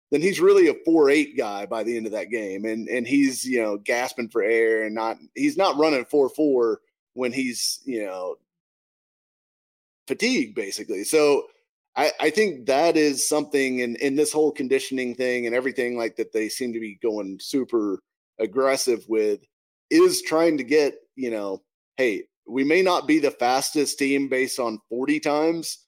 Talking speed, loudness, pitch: 175 wpm, -23 LUFS, 140 Hz